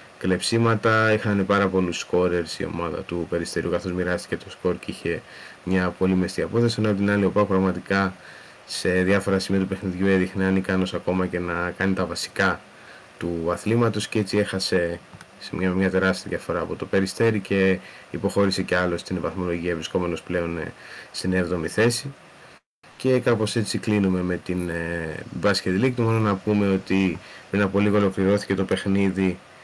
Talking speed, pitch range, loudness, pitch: 170 wpm, 90-100 Hz, -23 LUFS, 95 Hz